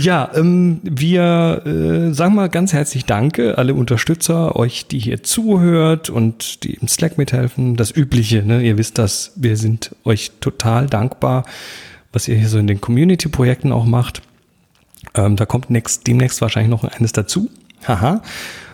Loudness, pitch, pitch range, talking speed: -16 LUFS, 125 Hz, 115-160 Hz, 165 wpm